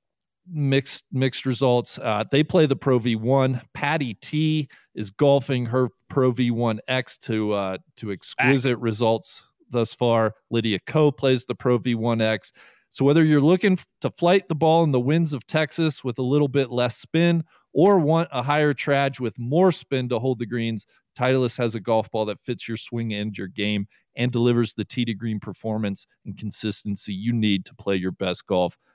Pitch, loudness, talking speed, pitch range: 125 Hz, -23 LUFS, 180 wpm, 110-140 Hz